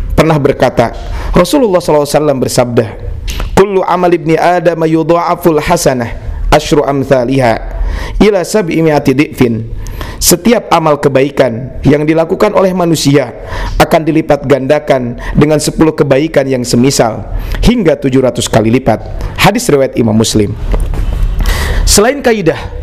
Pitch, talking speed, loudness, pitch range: 140 Hz, 110 wpm, -10 LUFS, 110-160 Hz